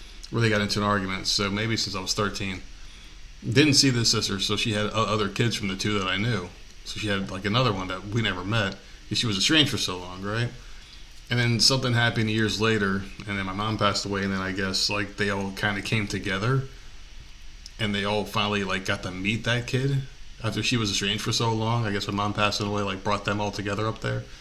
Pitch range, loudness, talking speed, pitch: 95-110 Hz, -25 LUFS, 235 wpm, 105 Hz